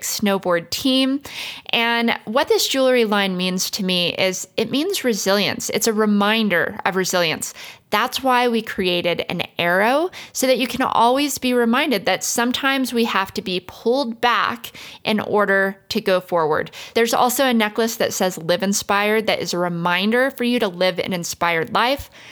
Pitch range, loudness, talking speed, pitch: 190-250 Hz, -19 LUFS, 170 wpm, 215 Hz